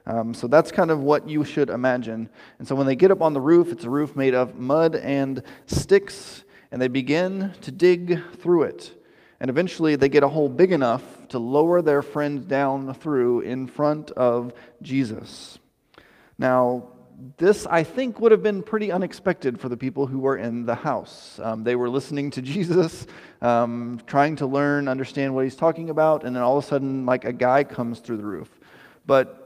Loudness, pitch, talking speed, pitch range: -22 LUFS, 140 Hz, 200 wpm, 125-160 Hz